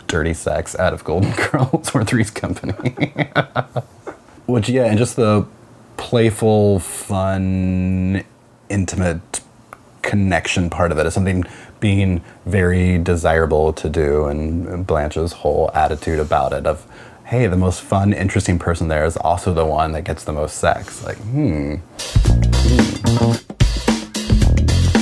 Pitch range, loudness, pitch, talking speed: 85-110 Hz, -18 LUFS, 95 Hz, 130 wpm